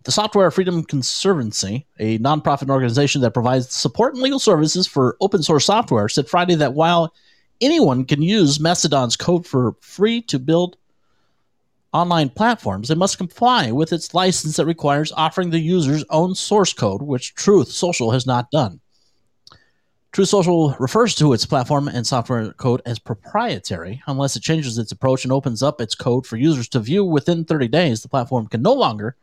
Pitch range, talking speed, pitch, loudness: 125-175 Hz, 175 wpm, 150 Hz, -18 LUFS